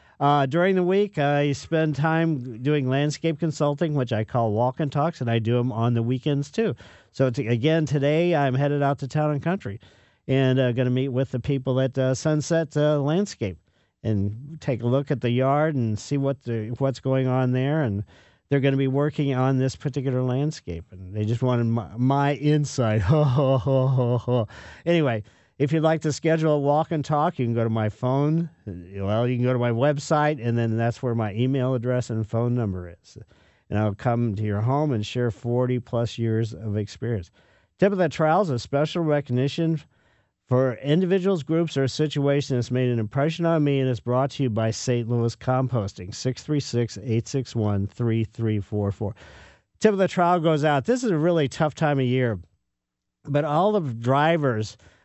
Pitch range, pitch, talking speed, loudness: 115-150 Hz, 130 Hz, 190 wpm, -24 LUFS